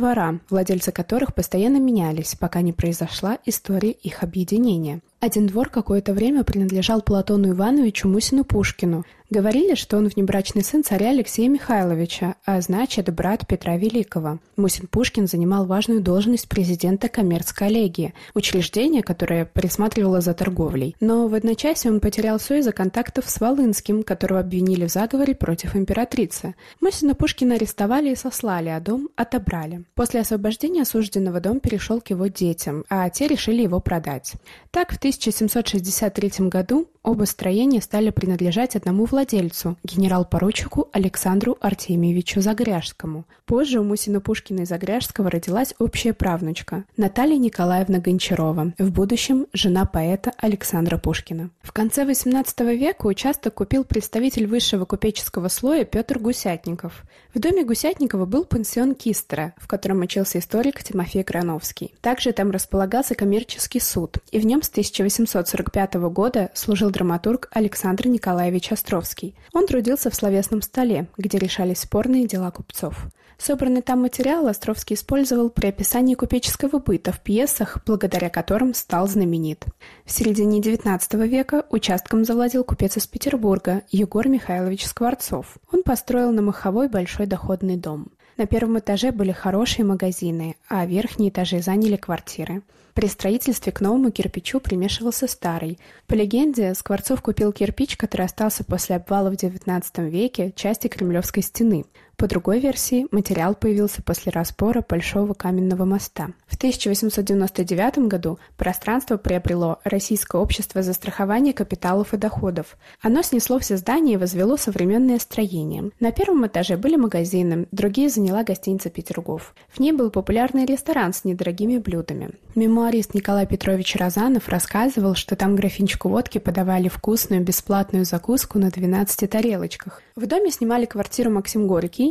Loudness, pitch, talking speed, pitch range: -21 LUFS, 205 Hz, 135 wpm, 185-235 Hz